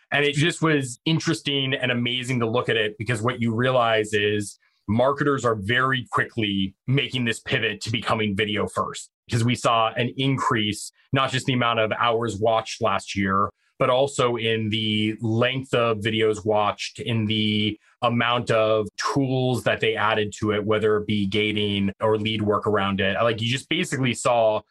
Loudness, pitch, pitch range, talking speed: -23 LUFS, 115 Hz, 105-125 Hz, 175 wpm